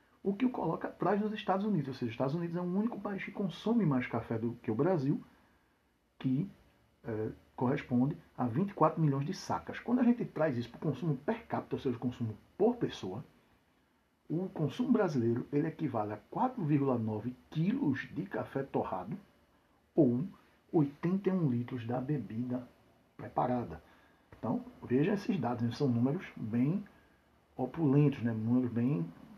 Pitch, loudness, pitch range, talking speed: 140 Hz, -34 LUFS, 120-185 Hz, 155 wpm